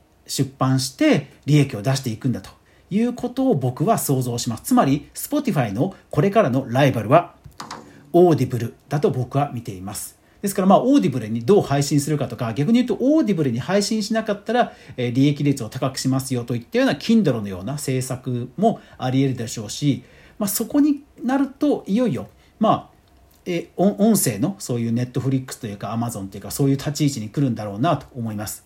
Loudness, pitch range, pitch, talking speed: -21 LUFS, 120-200 Hz, 135 Hz, 435 characters per minute